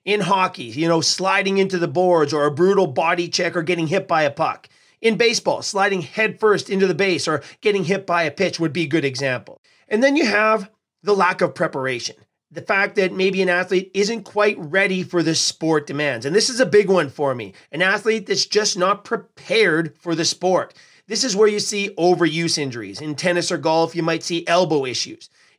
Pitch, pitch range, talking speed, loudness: 180 Hz, 165-200 Hz, 215 wpm, -19 LUFS